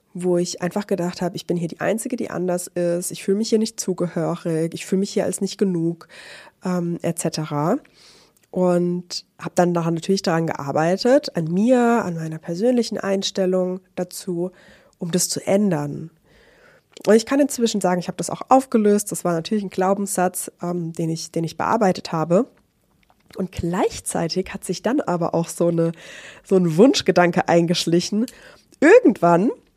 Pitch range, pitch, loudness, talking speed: 170-205 Hz, 180 Hz, -21 LUFS, 165 wpm